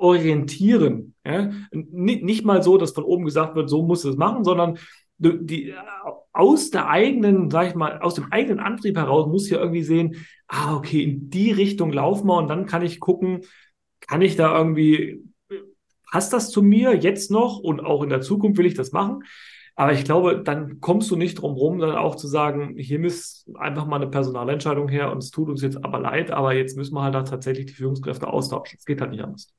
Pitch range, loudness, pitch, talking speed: 145-185 Hz, -21 LUFS, 165 Hz, 220 wpm